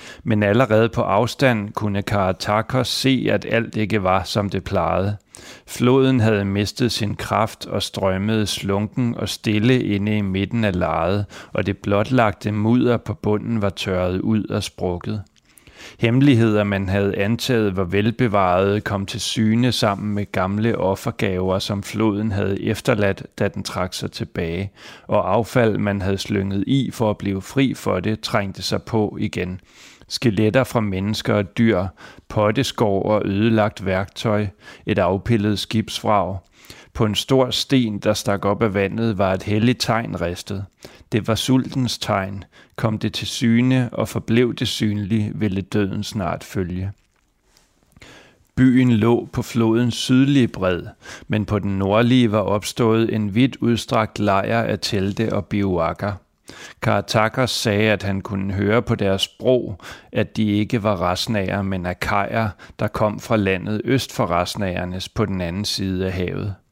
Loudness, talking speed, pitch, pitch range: -20 LUFS, 150 wpm, 105 Hz, 100-115 Hz